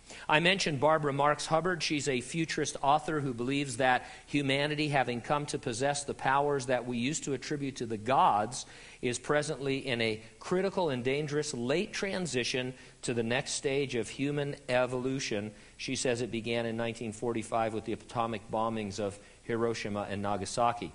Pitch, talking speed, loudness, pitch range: 130 Hz, 165 wpm, -31 LUFS, 115-145 Hz